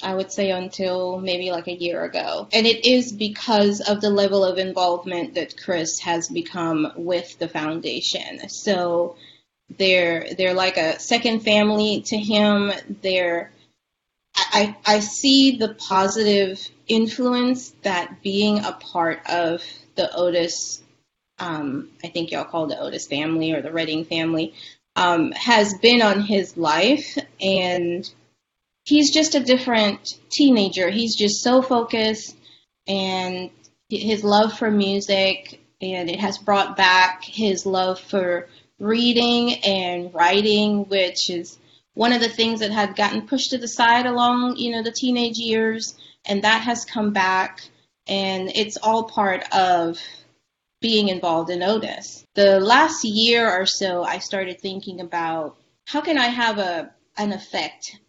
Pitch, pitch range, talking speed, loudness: 200 Hz, 180-225 Hz, 145 wpm, -20 LUFS